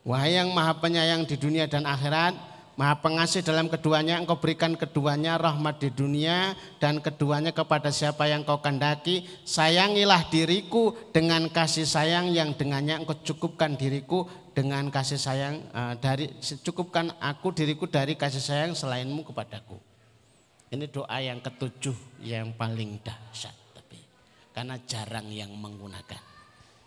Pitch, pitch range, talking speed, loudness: 150 Hz, 130-165 Hz, 135 wpm, -26 LUFS